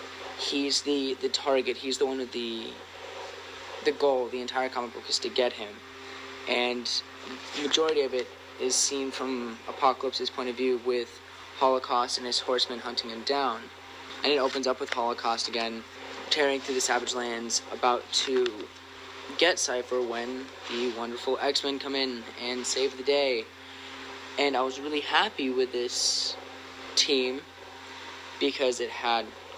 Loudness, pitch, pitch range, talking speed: -28 LUFS, 130 Hz, 120-140 Hz, 155 wpm